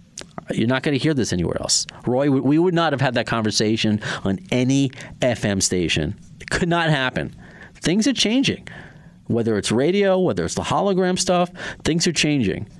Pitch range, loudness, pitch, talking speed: 115-180 Hz, -20 LUFS, 140 Hz, 180 wpm